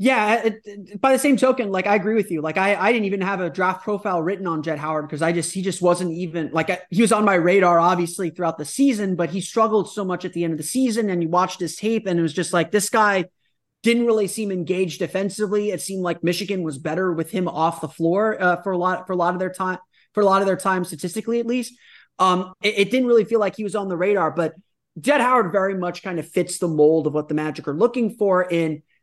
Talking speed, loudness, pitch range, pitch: 270 wpm, -21 LUFS, 175-210 Hz, 185 Hz